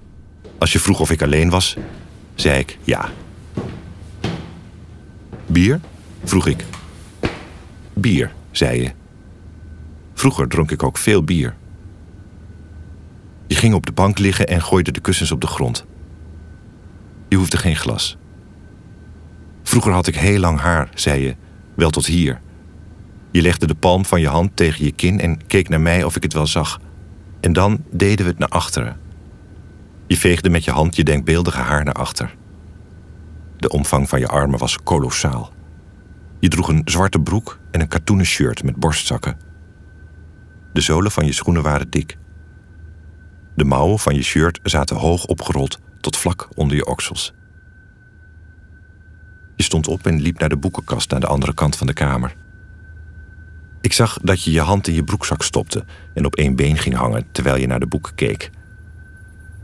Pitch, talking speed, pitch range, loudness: 85 Hz, 160 wpm, 80-95 Hz, -18 LUFS